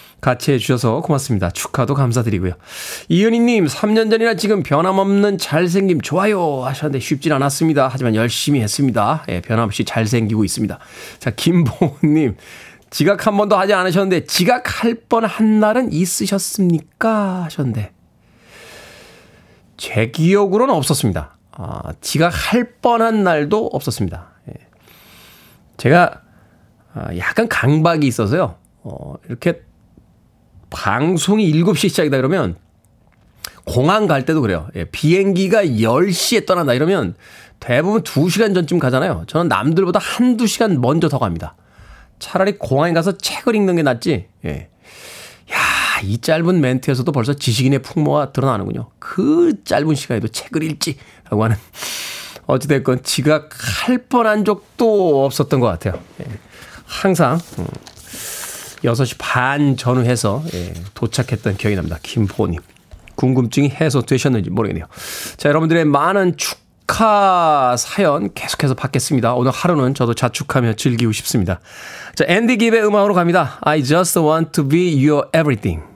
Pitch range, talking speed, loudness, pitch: 120-185 Hz, 315 characters per minute, -16 LUFS, 150 Hz